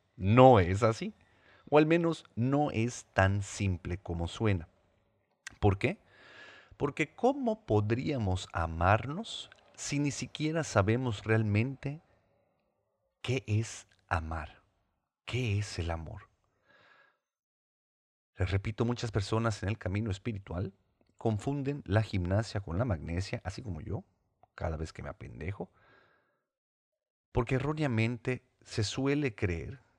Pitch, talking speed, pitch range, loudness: 110 Hz, 115 wpm, 95-125 Hz, -32 LUFS